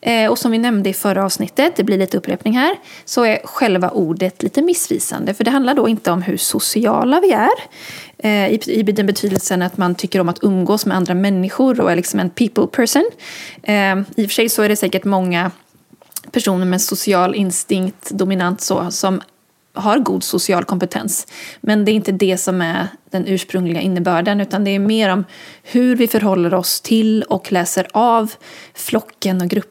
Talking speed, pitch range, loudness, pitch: 185 wpm, 185-225 Hz, -16 LUFS, 195 Hz